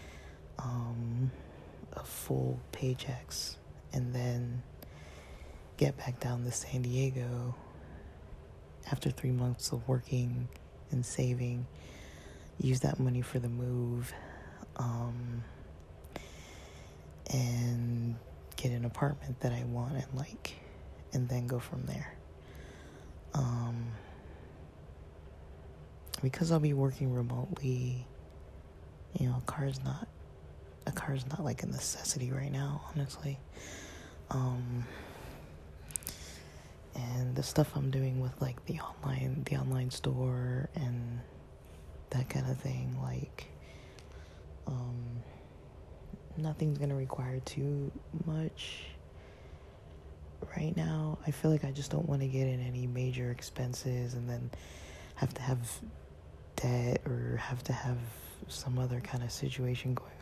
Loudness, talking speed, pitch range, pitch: -36 LUFS, 115 wpm, 80-130 Hz, 120 Hz